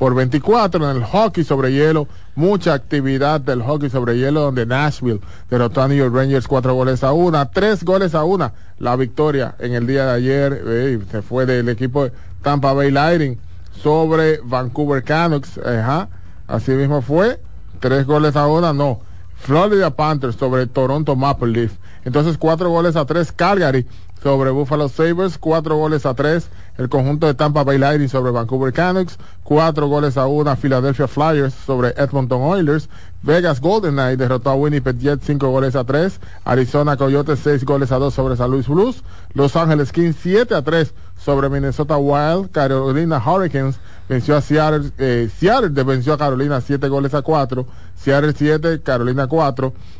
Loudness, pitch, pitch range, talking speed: -17 LUFS, 140 Hz, 130-150 Hz, 170 wpm